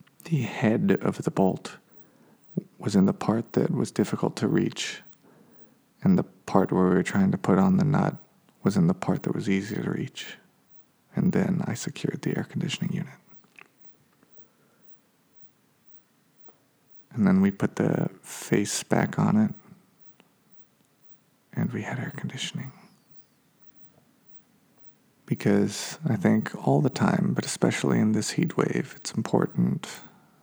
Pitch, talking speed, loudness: 170 Hz, 140 wpm, -26 LUFS